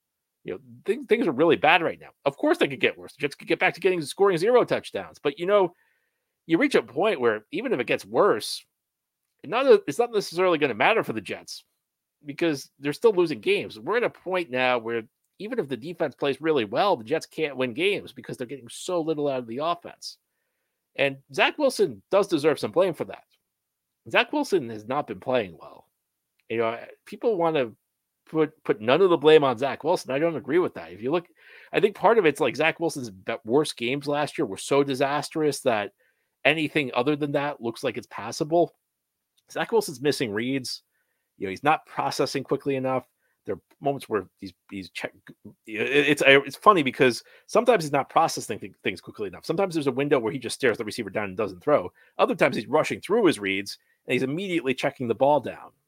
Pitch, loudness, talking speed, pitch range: 150 Hz, -24 LUFS, 215 wpm, 135-195 Hz